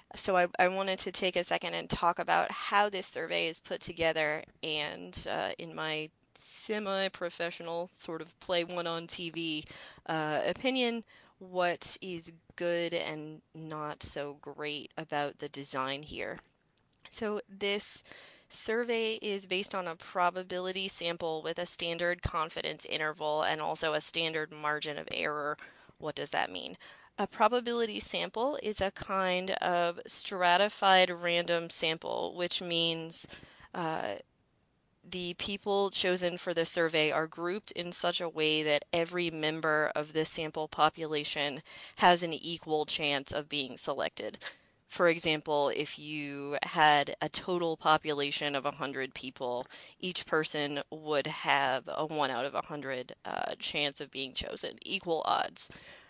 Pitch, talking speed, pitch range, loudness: 165 Hz, 140 wpm, 150-180 Hz, -32 LUFS